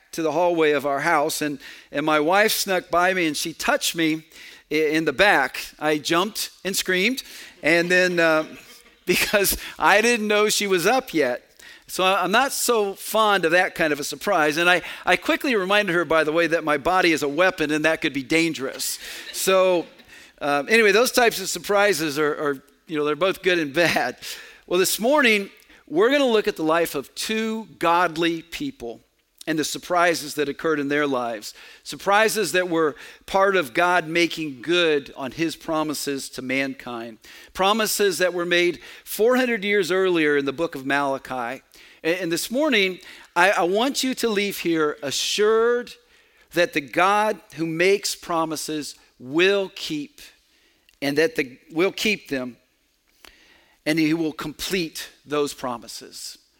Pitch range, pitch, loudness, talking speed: 150-205 Hz, 170 Hz, -21 LUFS, 170 wpm